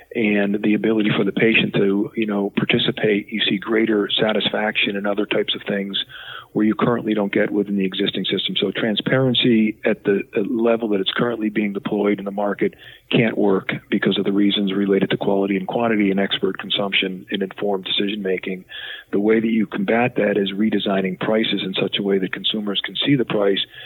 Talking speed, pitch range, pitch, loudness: 195 wpm, 100-110 Hz, 100 Hz, -20 LUFS